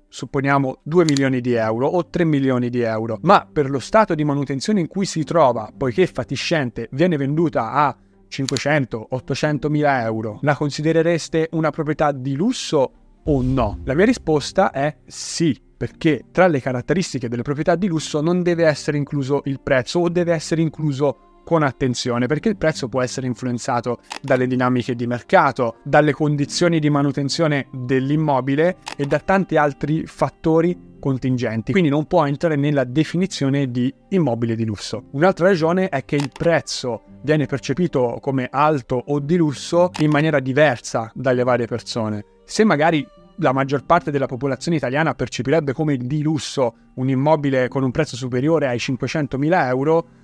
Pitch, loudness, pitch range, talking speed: 145 Hz, -20 LUFS, 130-160 Hz, 160 wpm